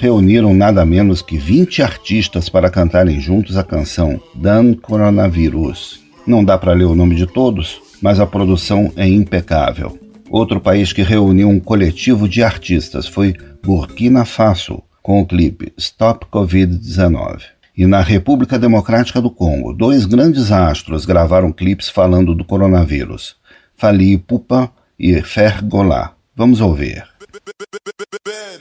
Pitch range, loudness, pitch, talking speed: 90-110 Hz, -13 LUFS, 100 Hz, 130 wpm